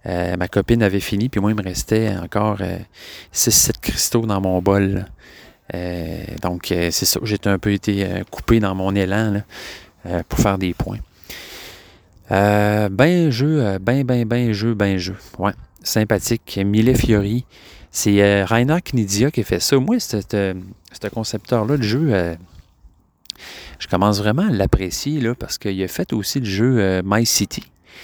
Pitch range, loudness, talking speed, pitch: 95-115 Hz, -19 LUFS, 175 wpm, 100 Hz